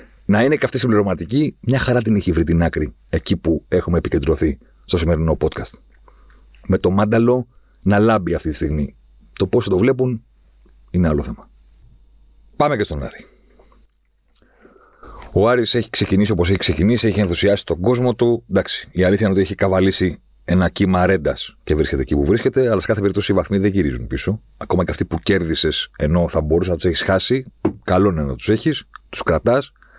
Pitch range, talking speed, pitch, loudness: 80-110 Hz, 185 wpm, 95 Hz, -18 LUFS